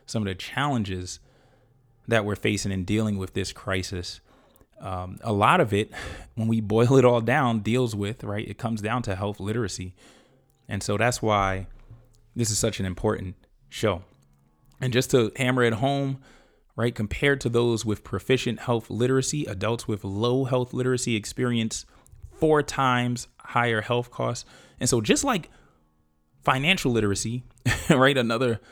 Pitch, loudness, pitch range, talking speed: 115 Hz, -25 LUFS, 100-125 Hz, 155 wpm